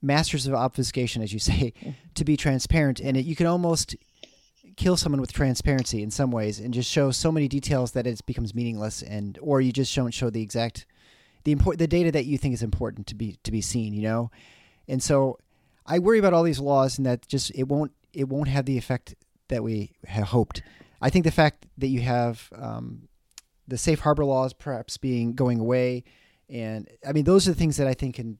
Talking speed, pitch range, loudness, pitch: 220 wpm, 115-145 Hz, -25 LUFS, 130 Hz